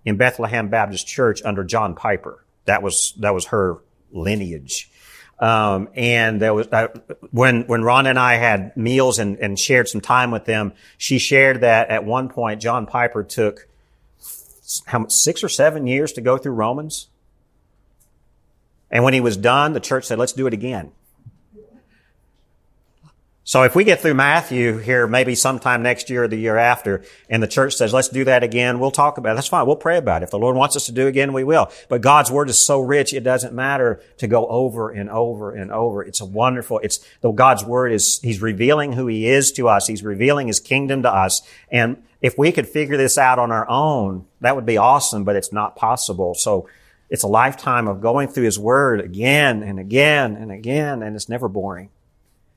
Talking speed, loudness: 205 wpm, -17 LUFS